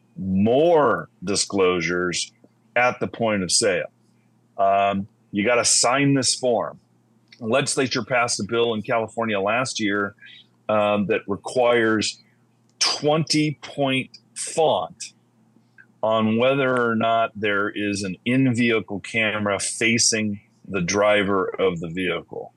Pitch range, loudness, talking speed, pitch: 100-120 Hz, -21 LUFS, 115 wpm, 110 Hz